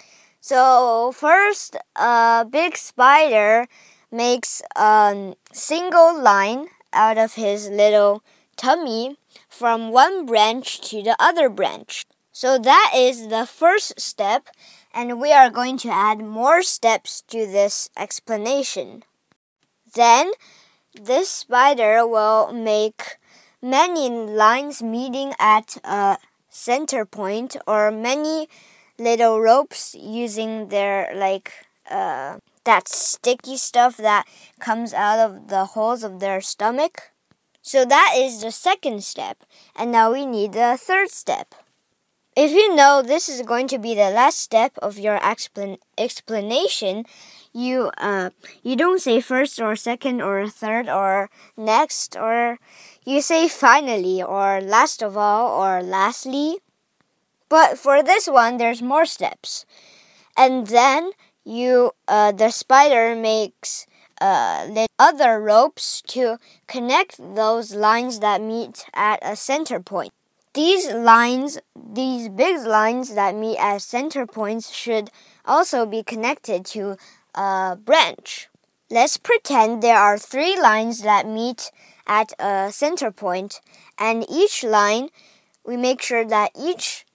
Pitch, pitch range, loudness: 230 Hz, 215-270 Hz, -18 LUFS